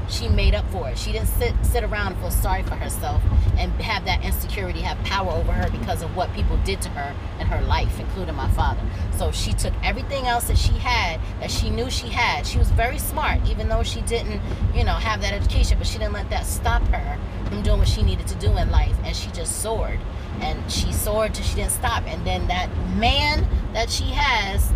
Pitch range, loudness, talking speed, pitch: 90-95 Hz, -23 LUFS, 235 wpm, 90 Hz